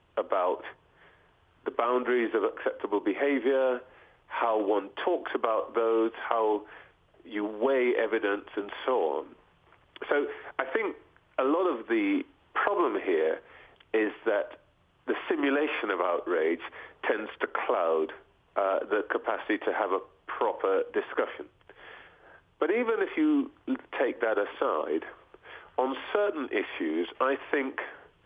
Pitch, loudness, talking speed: 345 Hz, -29 LUFS, 120 wpm